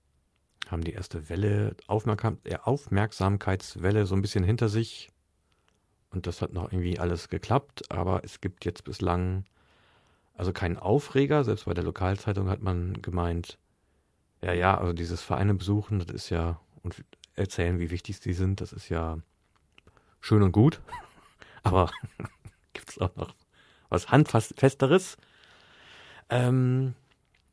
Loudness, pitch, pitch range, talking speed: -28 LUFS, 95 Hz, 85-110 Hz, 135 wpm